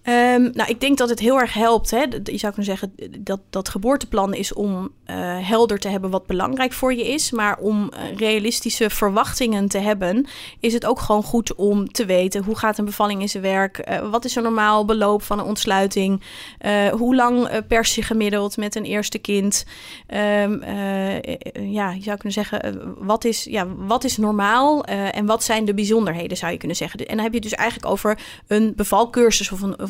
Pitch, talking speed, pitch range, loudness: 210 Hz, 215 wpm, 200-230 Hz, -20 LUFS